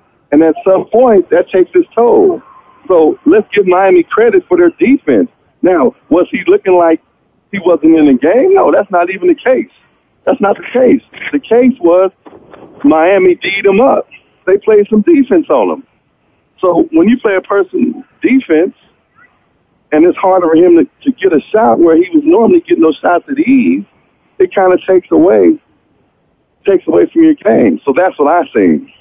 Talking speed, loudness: 185 wpm, -9 LUFS